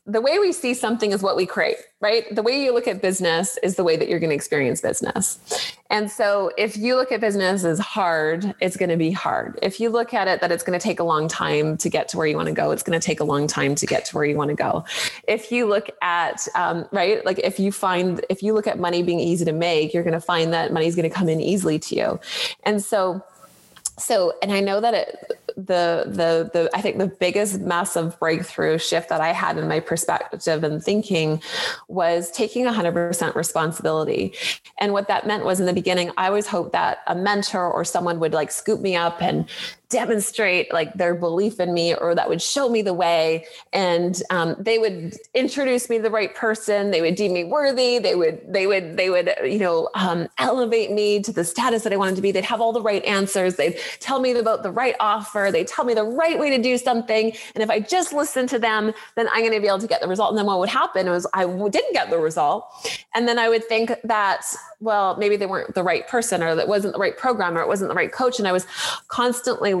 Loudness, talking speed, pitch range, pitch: -21 LUFS, 250 wpm, 175-225 Hz, 200 Hz